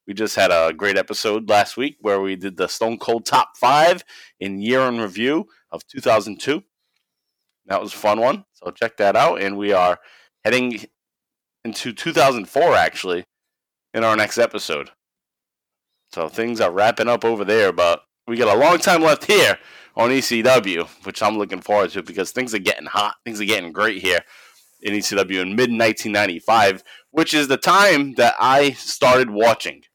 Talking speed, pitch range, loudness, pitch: 175 wpm, 100-120 Hz, -18 LUFS, 110 Hz